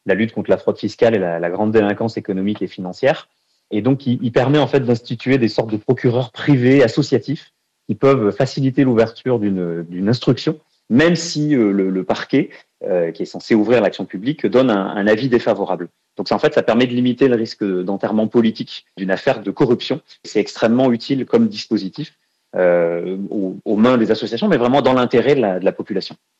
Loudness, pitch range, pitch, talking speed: -17 LUFS, 100-130 Hz, 115 Hz, 200 wpm